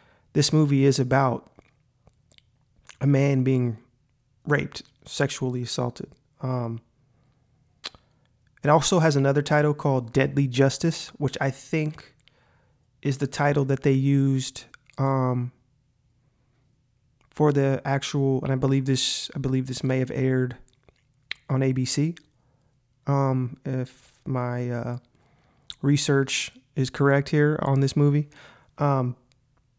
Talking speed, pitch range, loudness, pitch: 115 wpm, 130-140 Hz, -24 LUFS, 135 Hz